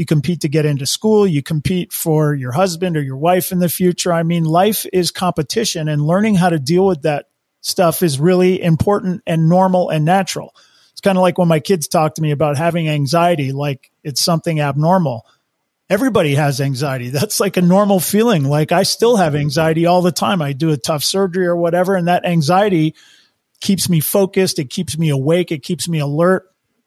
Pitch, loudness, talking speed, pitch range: 170 Hz, -15 LUFS, 205 wpm, 155-185 Hz